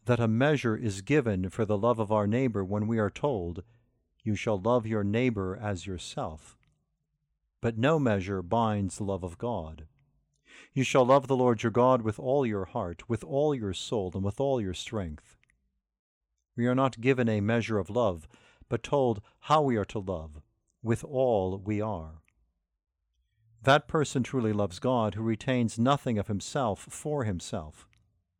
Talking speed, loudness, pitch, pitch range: 170 wpm, -29 LUFS, 110 Hz, 95-125 Hz